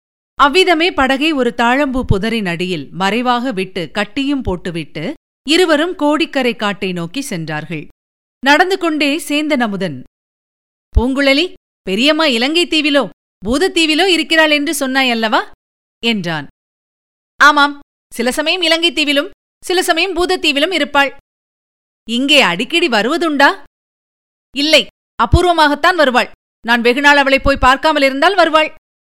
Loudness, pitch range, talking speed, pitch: -13 LUFS, 240-315 Hz, 95 wpm, 280 Hz